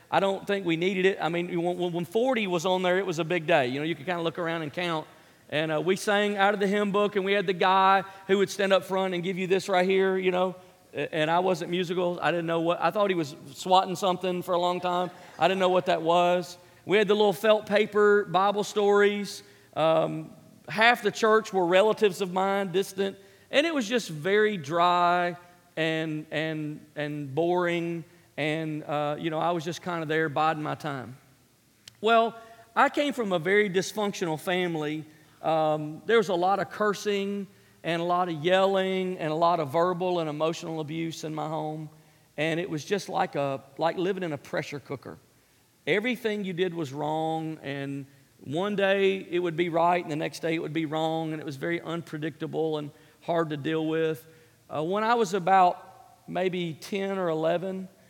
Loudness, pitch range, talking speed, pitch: -27 LUFS, 160-190 Hz, 210 wpm, 175 Hz